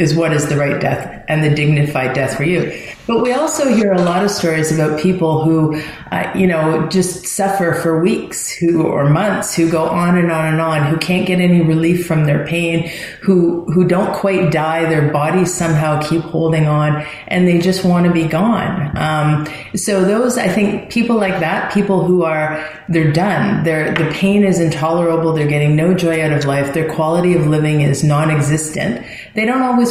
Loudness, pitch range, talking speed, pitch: -15 LUFS, 155-185 Hz, 200 wpm, 165 Hz